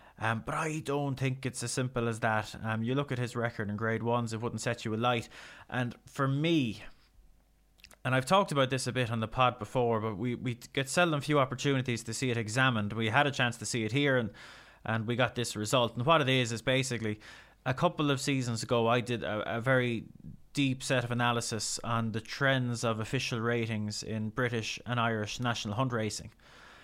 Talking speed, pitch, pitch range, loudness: 215 wpm, 120 Hz, 115-130 Hz, -31 LUFS